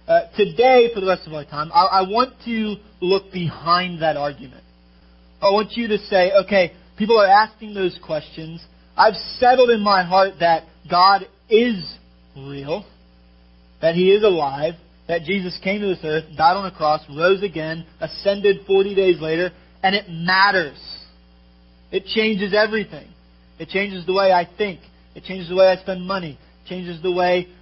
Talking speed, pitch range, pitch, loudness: 170 wpm, 155-200 Hz, 180 Hz, -19 LUFS